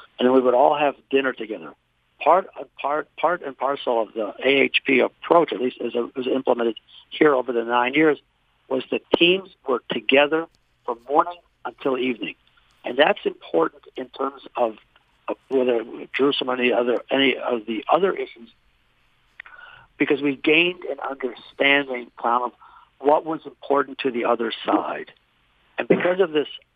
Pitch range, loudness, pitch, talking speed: 125-155 Hz, -22 LUFS, 135 Hz, 160 wpm